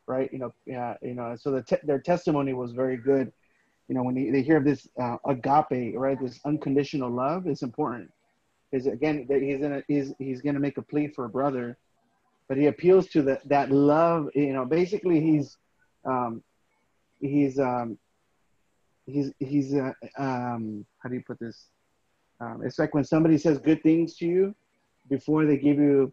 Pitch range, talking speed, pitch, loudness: 130-150 Hz, 190 wpm, 140 Hz, -26 LUFS